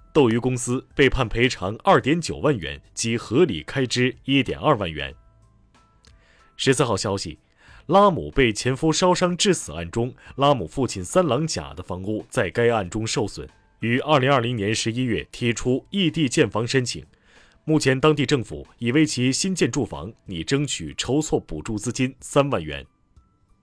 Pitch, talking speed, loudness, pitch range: 120 Hz, 245 characters per minute, -22 LUFS, 100-140 Hz